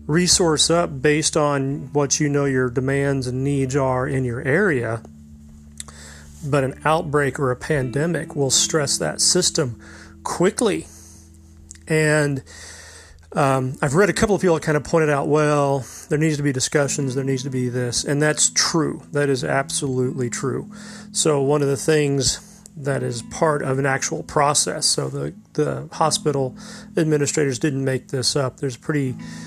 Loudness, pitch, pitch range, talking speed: -20 LUFS, 140 Hz, 125-155 Hz, 165 wpm